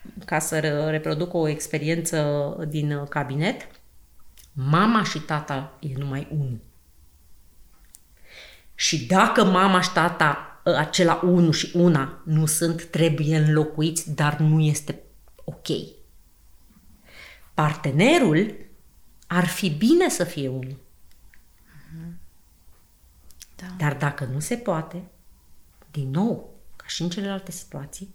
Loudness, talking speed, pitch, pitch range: -23 LUFS, 105 wpm, 155 Hz, 130-170 Hz